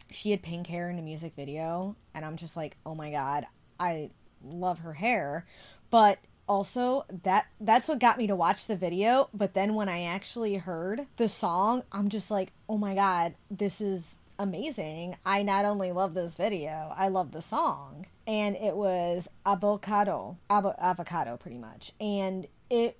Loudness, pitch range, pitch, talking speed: -30 LUFS, 170-205 Hz, 195 Hz, 170 wpm